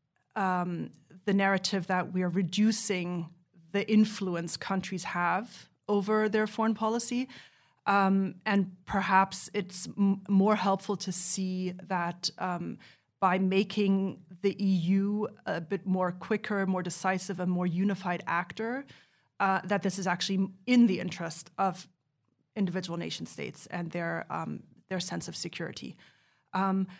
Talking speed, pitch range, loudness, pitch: 135 wpm, 180-200 Hz, -30 LUFS, 190 Hz